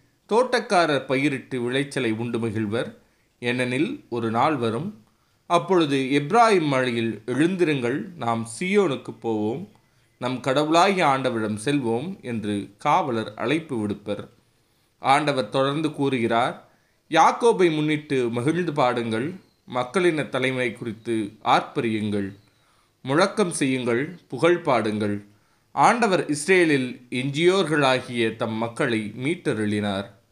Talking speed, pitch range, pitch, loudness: 90 wpm, 115-150 Hz, 125 Hz, -23 LUFS